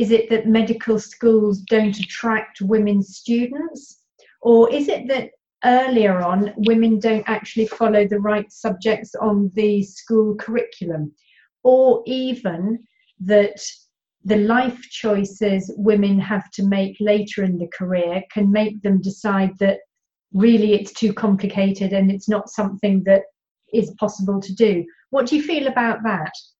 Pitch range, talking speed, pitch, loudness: 195-230 Hz, 145 wpm, 210 Hz, -19 LUFS